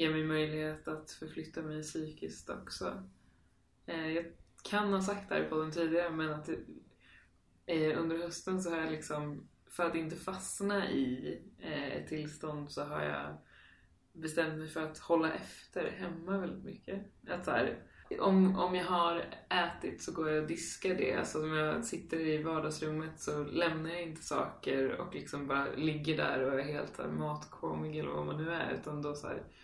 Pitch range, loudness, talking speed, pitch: 145-170 Hz, -36 LUFS, 180 wpm, 155 Hz